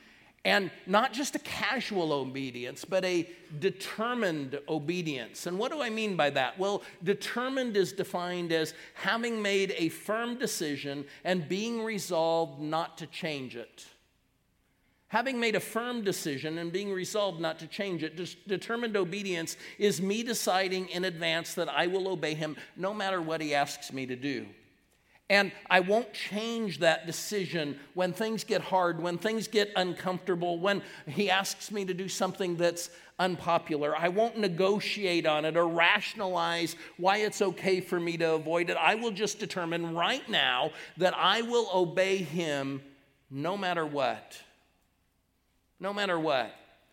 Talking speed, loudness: 155 wpm, -30 LUFS